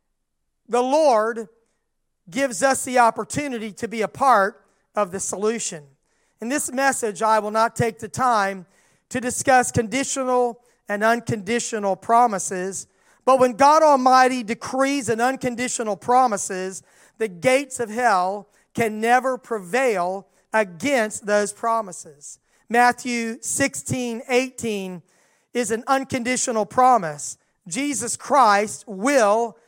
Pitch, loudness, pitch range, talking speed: 230 Hz, -21 LUFS, 205-255 Hz, 110 wpm